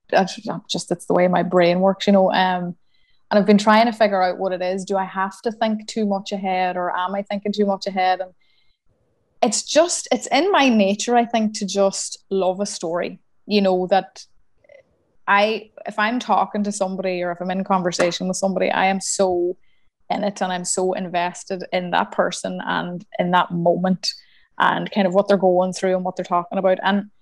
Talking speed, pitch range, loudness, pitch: 210 wpm, 185-205 Hz, -20 LUFS, 190 Hz